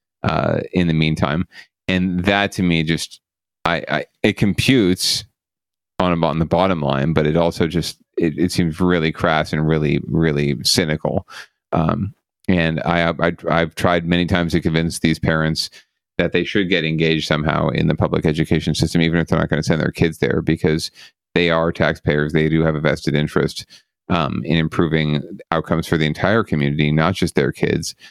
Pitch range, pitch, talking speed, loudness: 80-85 Hz, 80 Hz, 185 wpm, -18 LUFS